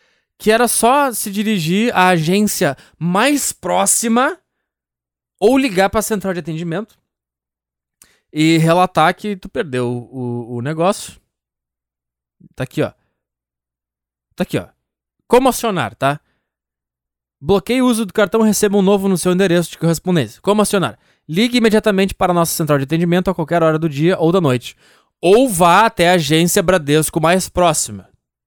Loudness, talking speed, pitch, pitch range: -15 LUFS, 150 wpm, 170 Hz, 120-200 Hz